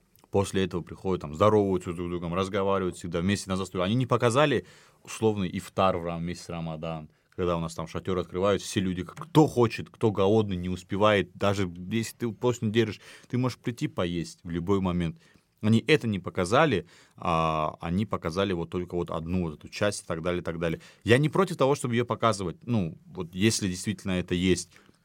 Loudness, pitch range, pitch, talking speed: -28 LUFS, 85-110 Hz, 95 Hz, 195 wpm